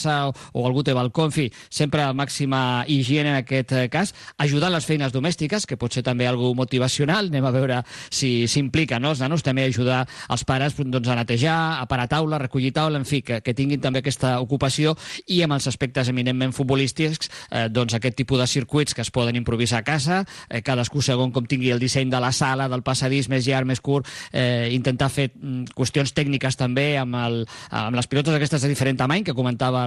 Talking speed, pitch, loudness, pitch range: 210 wpm, 135 Hz, -22 LUFS, 125-145 Hz